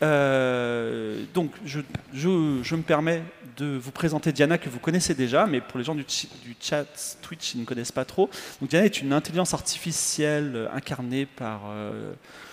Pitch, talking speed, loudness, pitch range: 145 Hz, 175 wpm, -26 LUFS, 130-160 Hz